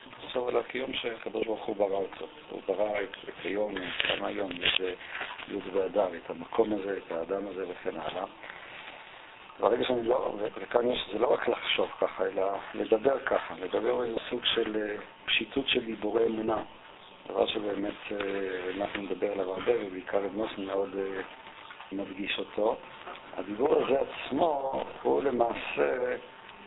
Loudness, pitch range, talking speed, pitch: -31 LUFS, 100-115 Hz, 140 wpm, 105 Hz